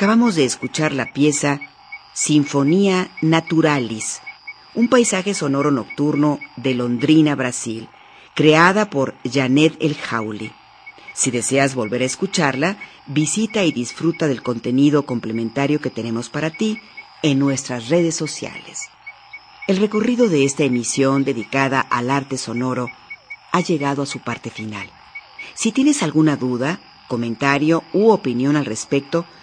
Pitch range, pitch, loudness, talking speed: 125-165 Hz, 140 Hz, -19 LUFS, 125 wpm